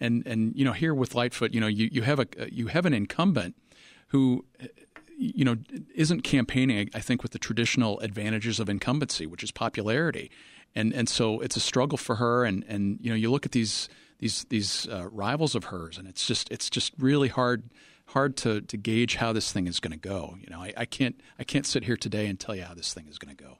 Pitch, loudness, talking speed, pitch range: 115 Hz, -28 LUFS, 235 wpm, 105-125 Hz